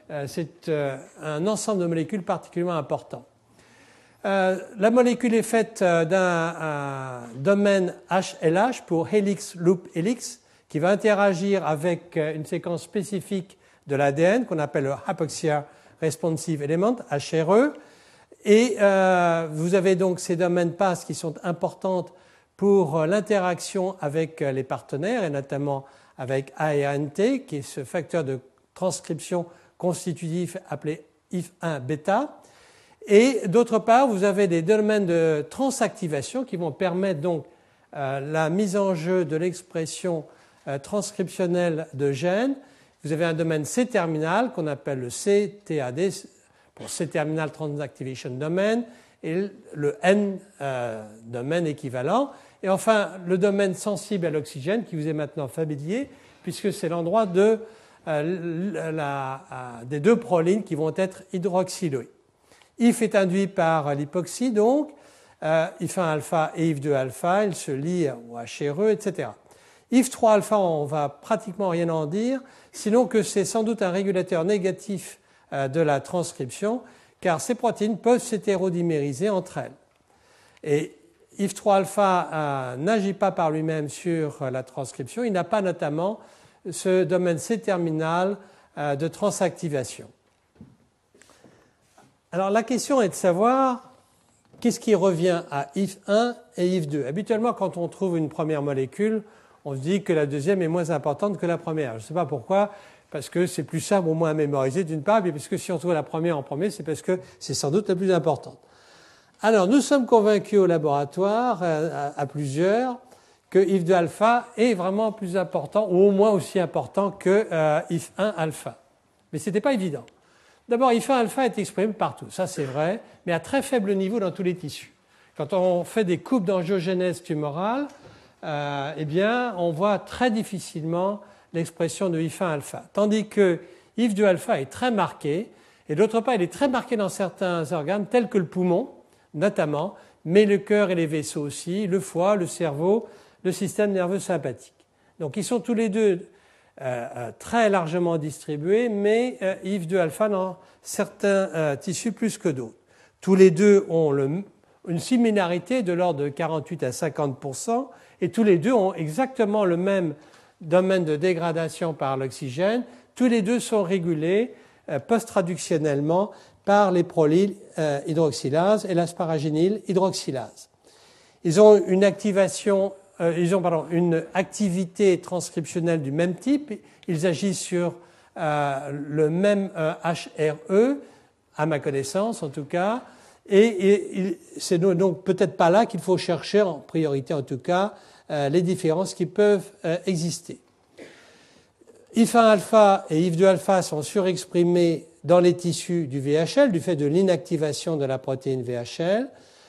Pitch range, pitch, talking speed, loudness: 160-205 Hz, 180 Hz, 150 wpm, -24 LUFS